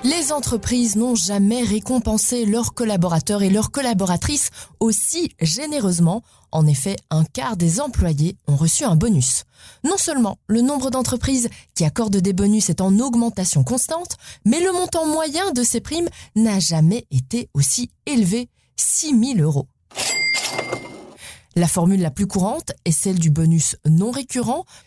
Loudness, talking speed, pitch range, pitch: -19 LUFS, 145 wpm, 175-250 Hz, 215 Hz